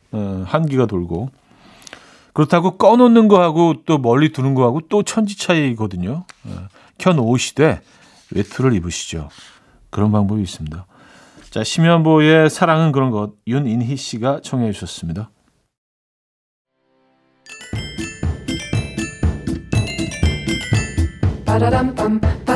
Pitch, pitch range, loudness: 125 Hz, 95-155 Hz, -17 LUFS